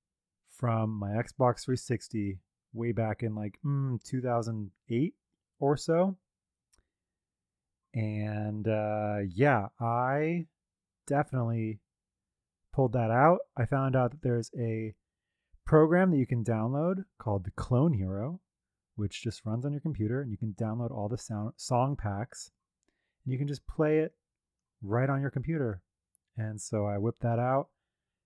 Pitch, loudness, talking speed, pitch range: 120 Hz, -31 LUFS, 140 wpm, 105-140 Hz